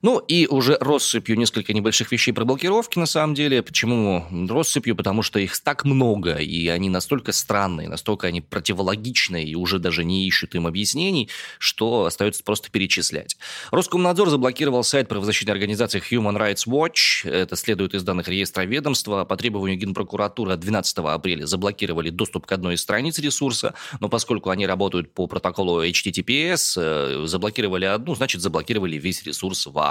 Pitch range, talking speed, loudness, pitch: 90-120 Hz, 155 wpm, -21 LUFS, 105 Hz